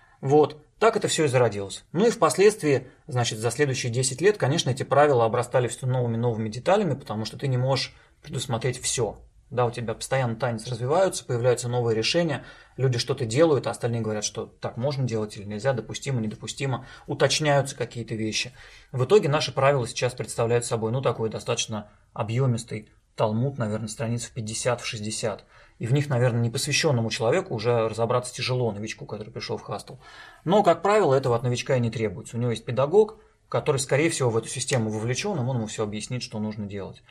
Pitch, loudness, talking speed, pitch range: 125 Hz, -25 LUFS, 185 wpm, 115-140 Hz